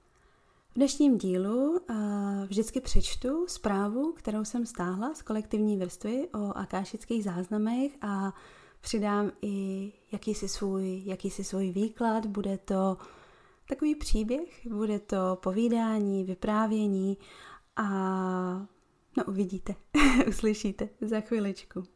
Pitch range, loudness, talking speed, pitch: 195-230 Hz, -31 LUFS, 105 wpm, 210 Hz